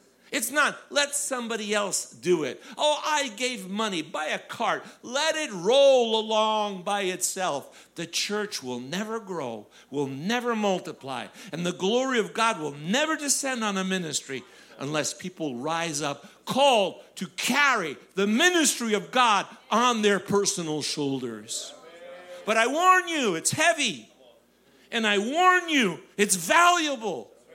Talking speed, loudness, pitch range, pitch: 145 wpm, -25 LUFS, 170-260 Hz, 210 Hz